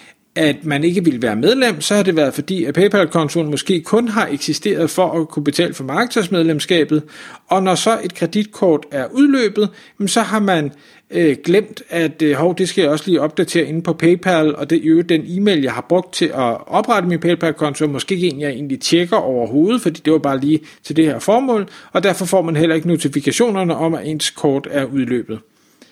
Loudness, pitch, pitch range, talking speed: -16 LUFS, 165 Hz, 150-190 Hz, 205 wpm